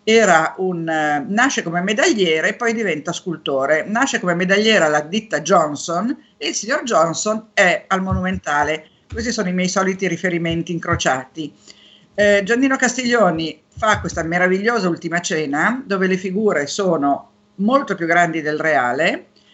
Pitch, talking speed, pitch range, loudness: 180 Hz, 140 wpm, 160-215 Hz, -18 LUFS